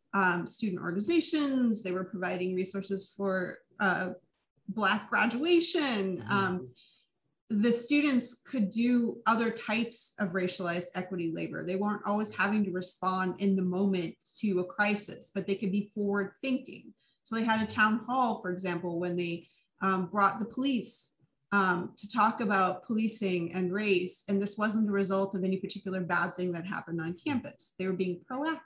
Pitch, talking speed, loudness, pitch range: 195 Hz, 165 wpm, -31 LUFS, 185-220 Hz